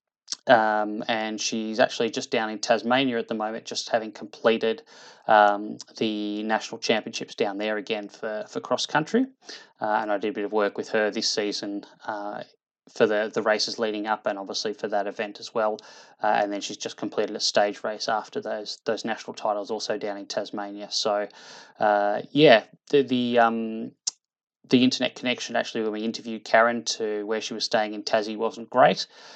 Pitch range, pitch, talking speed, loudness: 105-115 Hz, 110 Hz, 190 wpm, -25 LUFS